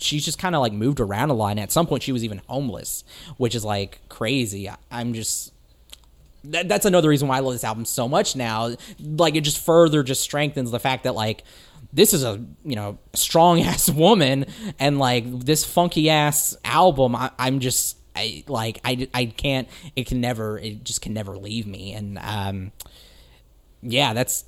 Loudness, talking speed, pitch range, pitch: -21 LUFS, 200 wpm, 110-150 Hz, 125 Hz